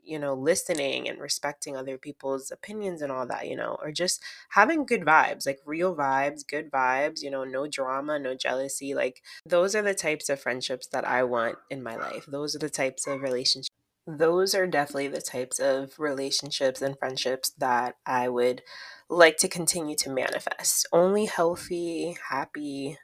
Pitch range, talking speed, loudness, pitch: 135-165 Hz, 175 wpm, -27 LUFS, 140 Hz